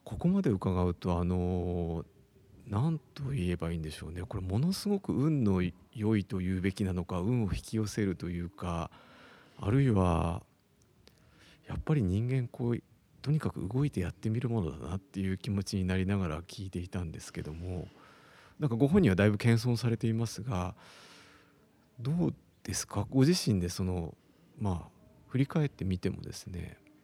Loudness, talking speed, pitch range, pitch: -32 LUFS, 320 characters per minute, 90-120 Hz, 100 Hz